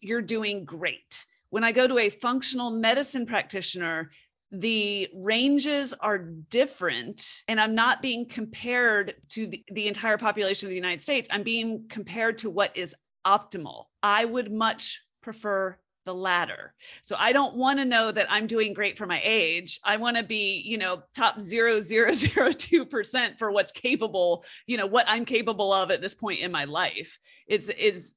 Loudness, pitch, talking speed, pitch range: -25 LUFS, 215 Hz, 175 wpm, 195-235 Hz